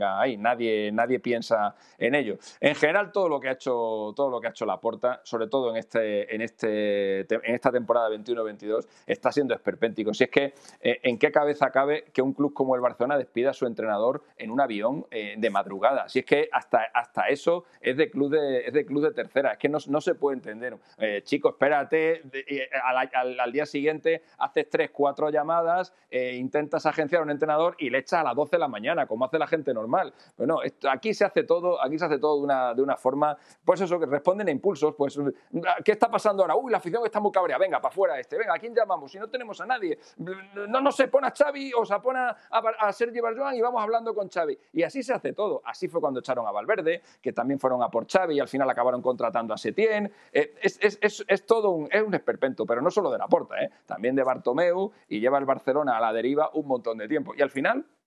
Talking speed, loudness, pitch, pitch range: 245 wpm, -26 LUFS, 150 Hz, 125-205 Hz